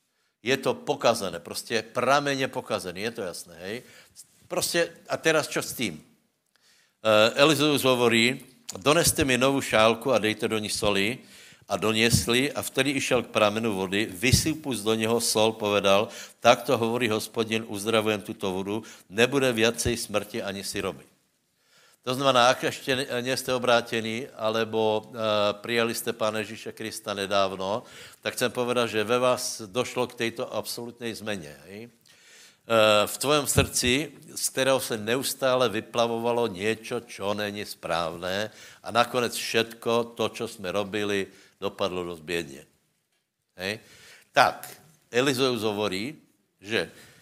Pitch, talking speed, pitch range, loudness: 115 Hz, 130 wpm, 105-125 Hz, -25 LUFS